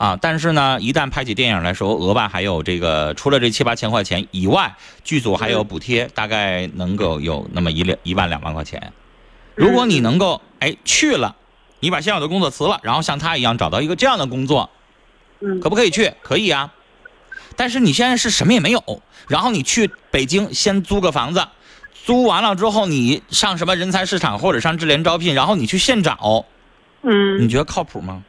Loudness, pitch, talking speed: -17 LUFS, 150 Hz, 310 characters per minute